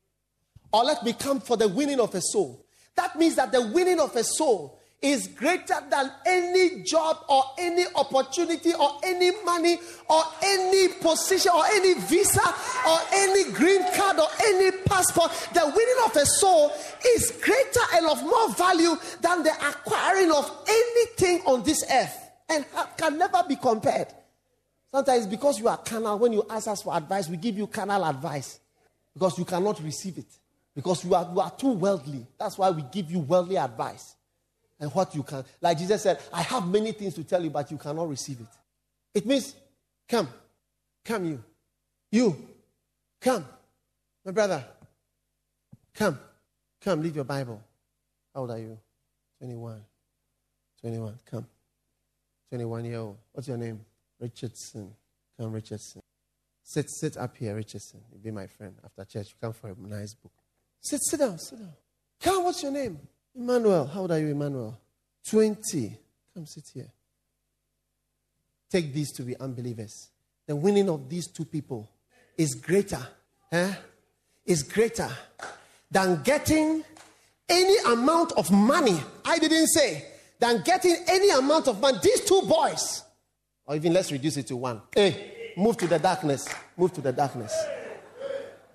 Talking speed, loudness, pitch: 160 wpm, -25 LUFS, 200 Hz